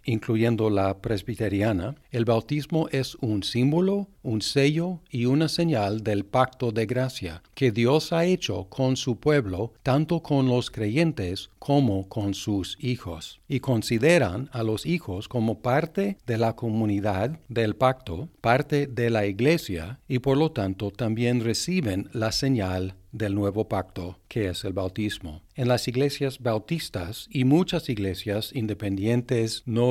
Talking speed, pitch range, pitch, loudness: 145 wpm, 105-140 Hz, 115 Hz, -26 LUFS